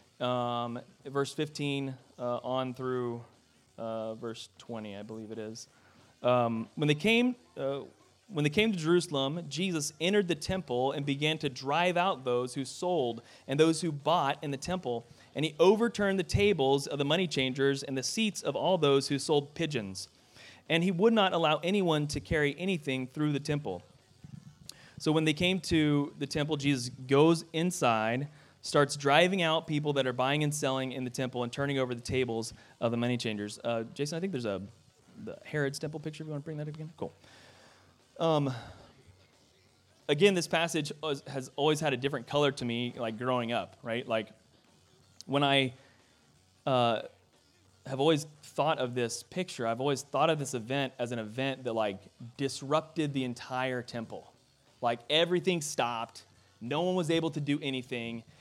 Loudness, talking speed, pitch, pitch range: -31 LUFS, 180 wpm, 140 Hz, 120-155 Hz